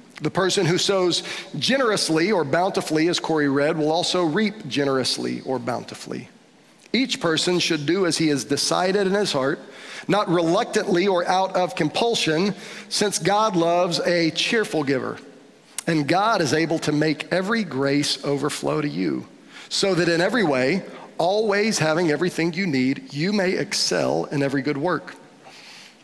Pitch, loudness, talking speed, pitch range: 170 Hz, -22 LUFS, 155 wpm, 150-195 Hz